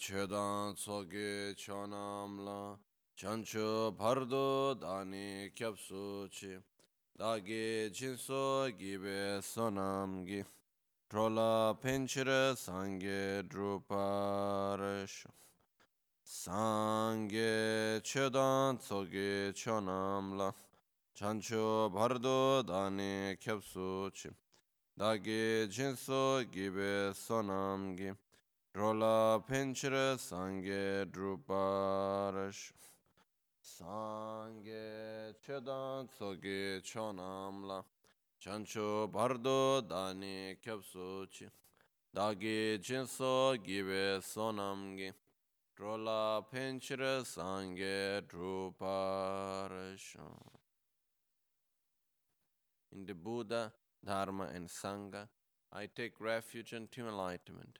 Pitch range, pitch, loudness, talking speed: 95-110 Hz, 100 Hz, -38 LUFS, 60 wpm